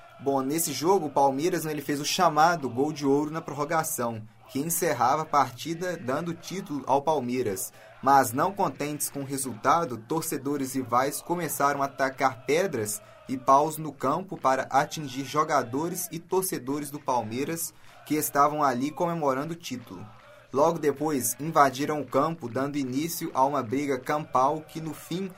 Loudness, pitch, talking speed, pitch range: -27 LUFS, 145 Hz, 155 wpm, 135-160 Hz